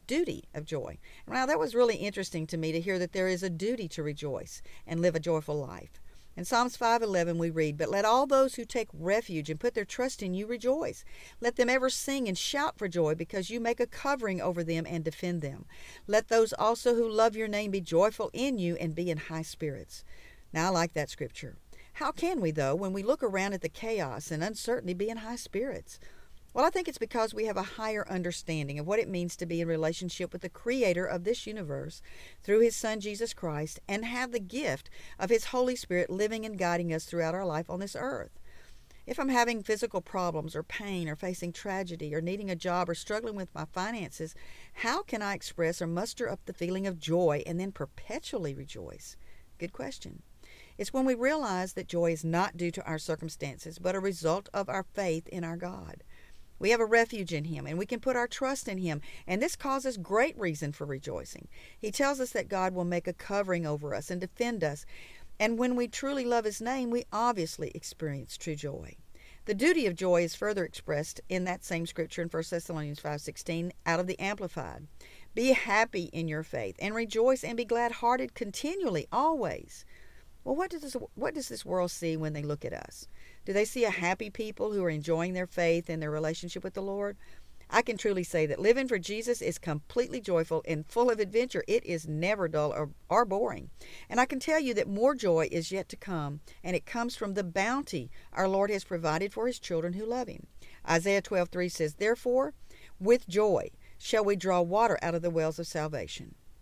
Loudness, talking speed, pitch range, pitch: -31 LUFS, 215 wpm, 165-230 Hz, 185 Hz